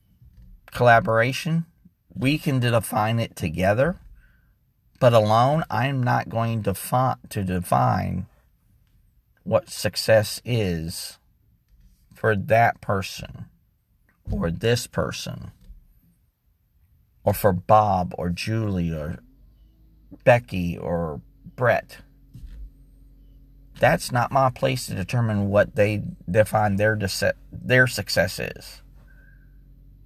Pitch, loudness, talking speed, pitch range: 110 Hz, -22 LUFS, 95 wpm, 95-125 Hz